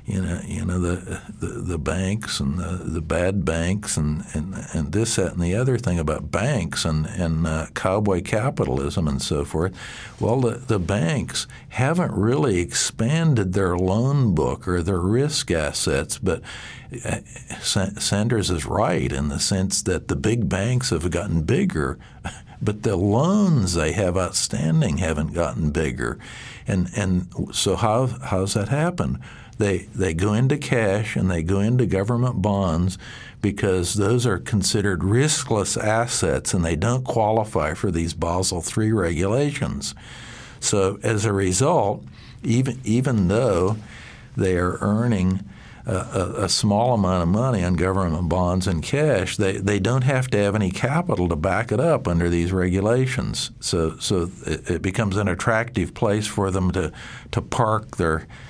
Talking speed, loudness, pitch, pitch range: 155 wpm, -22 LUFS, 95 Hz, 90-115 Hz